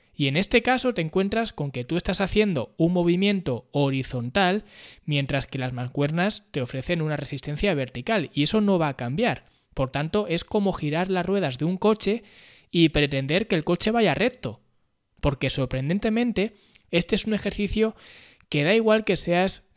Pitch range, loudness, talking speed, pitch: 145-205 Hz, -24 LUFS, 175 wpm, 175 Hz